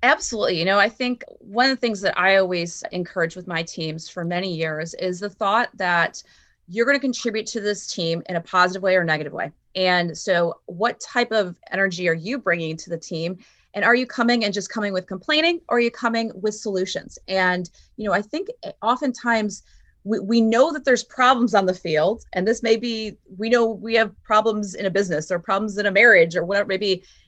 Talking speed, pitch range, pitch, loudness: 220 wpm, 180-230 Hz, 200 Hz, -21 LUFS